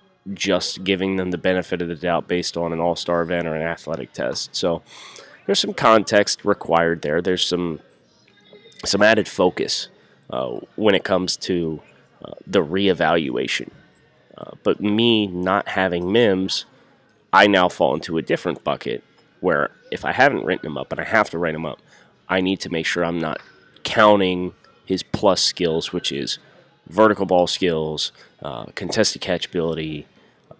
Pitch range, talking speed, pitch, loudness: 85-95 Hz, 165 wpm, 90 Hz, -20 LUFS